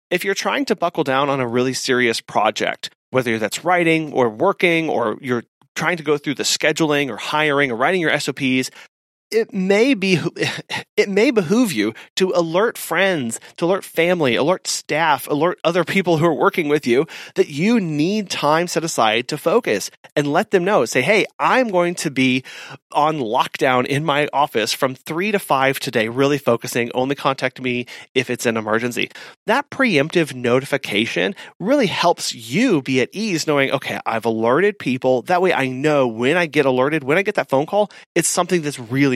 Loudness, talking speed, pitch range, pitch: -19 LUFS, 185 wpm, 130-180 Hz, 150 Hz